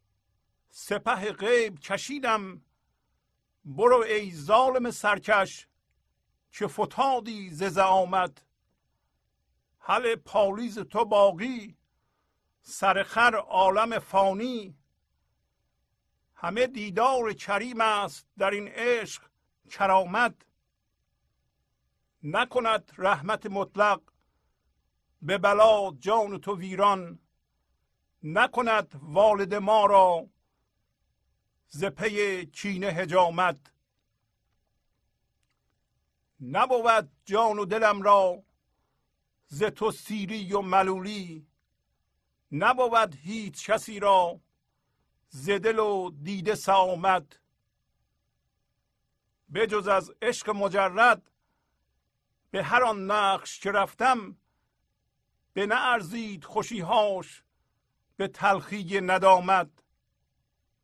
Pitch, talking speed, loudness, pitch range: 200 Hz, 75 wpm, -26 LUFS, 180-220 Hz